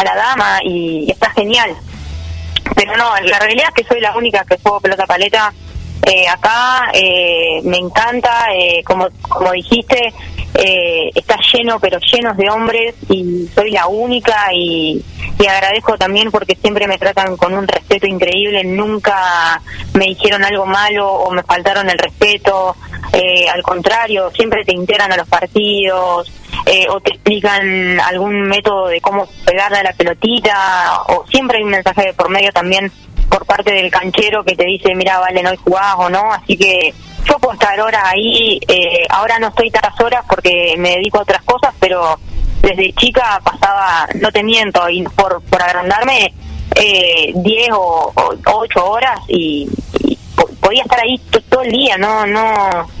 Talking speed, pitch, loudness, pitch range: 170 wpm, 195 Hz, -12 LUFS, 180-225 Hz